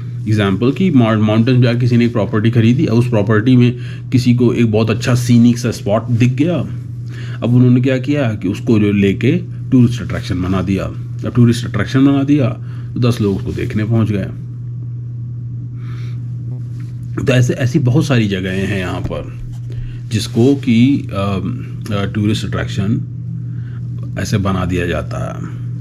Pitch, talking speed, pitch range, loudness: 120 Hz, 155 wpm, 110-125 Hz, -15 LUFS